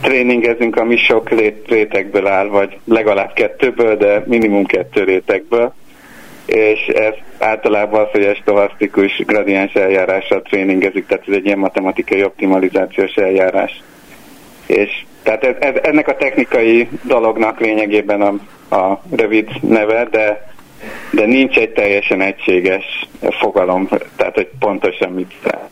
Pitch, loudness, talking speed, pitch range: 105 Hz, -14 LUFS, 125 wpm, 100-115 Hz